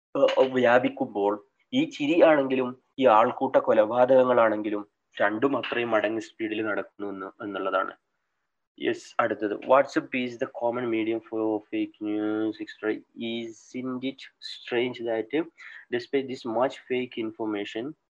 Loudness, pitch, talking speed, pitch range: -26 LUFS, 125 Hz, 95 wpm, 110-140 Hz